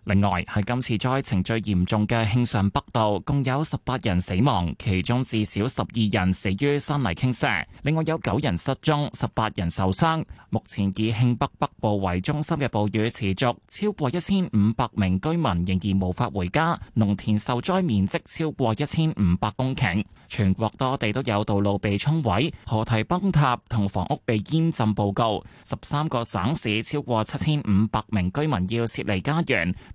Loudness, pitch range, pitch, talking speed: -24 LUFS, 100-140 Hz, 110 Hz, 265 characters per minute